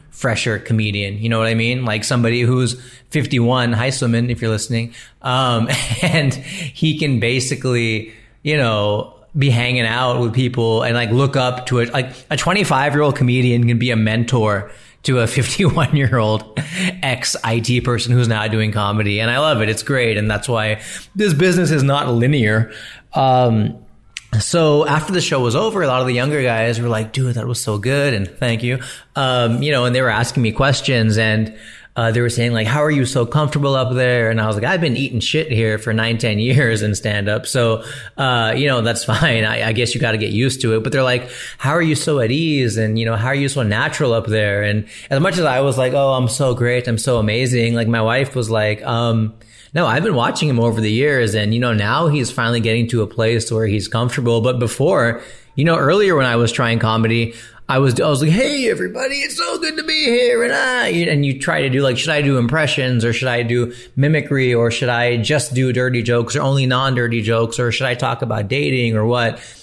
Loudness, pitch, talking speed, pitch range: -17 LUFS, 125 Hz, 225 wpm, 115-135 Hz